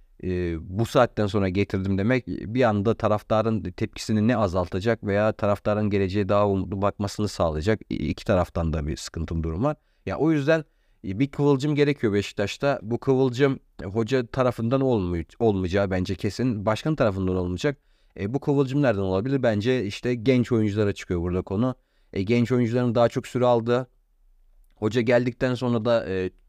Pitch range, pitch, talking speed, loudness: 95-125 Hz, 110 Hz, 160 wpm, -24 LUFS